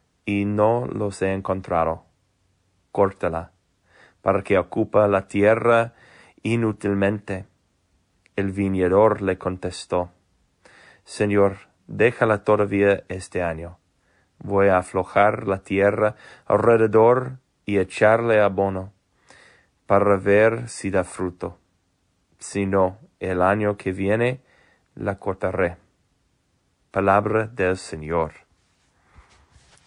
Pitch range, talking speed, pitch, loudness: 90-105 Hz, 90 wpm, 95 Hz, -21 LUFS